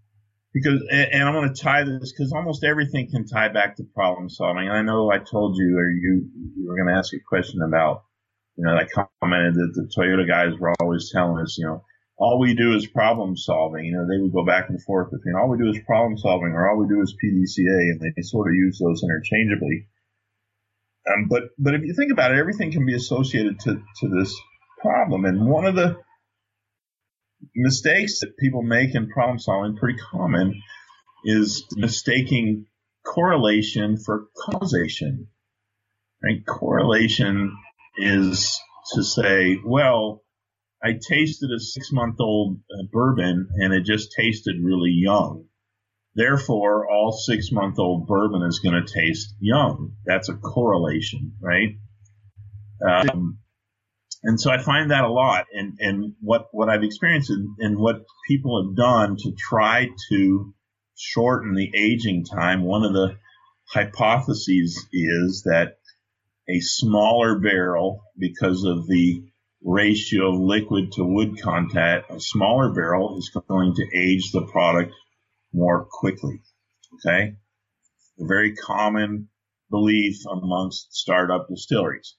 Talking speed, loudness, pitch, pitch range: 155 wpm, -21 LUFS, 105 Hz, 95-115 Hz